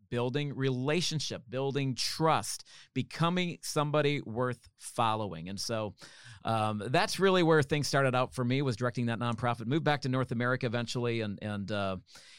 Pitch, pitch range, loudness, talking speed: 125 Hz, 115-145 Hz, -31 LUFS, 155 wpm